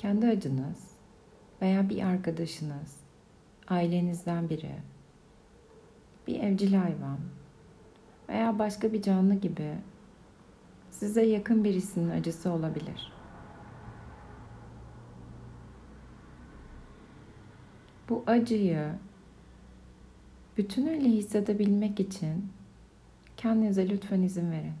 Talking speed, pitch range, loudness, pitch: 70 wpm, 160-210 Hz, -29 LUFS, 190 Hz